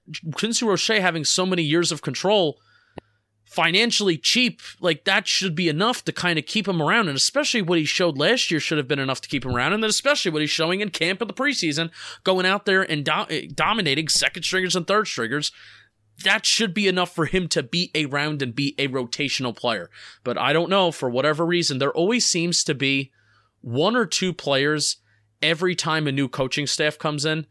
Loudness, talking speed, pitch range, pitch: -21 LUFS, 210 wpm, 145-190 Hz, 165 Hz